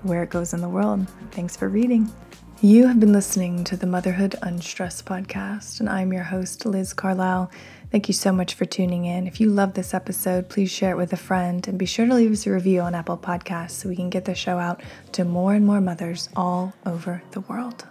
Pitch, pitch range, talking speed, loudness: 185 Hz, 180-200 Hz, 230 wpm, -23 LUFS